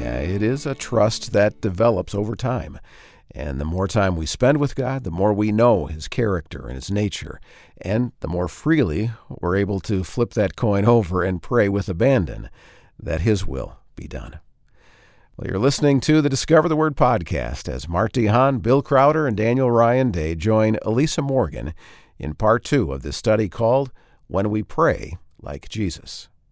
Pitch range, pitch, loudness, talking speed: 90-125 Hz, 105 Hz, -20 LUFS, 180 wpm